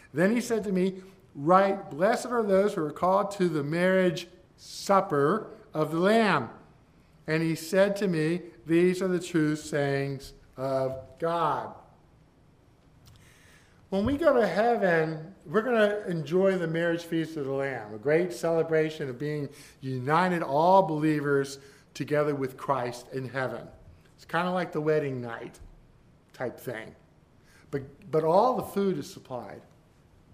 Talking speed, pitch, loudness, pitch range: 150 wpm, 165 Hz, -27 LUFS, 145-190 Hz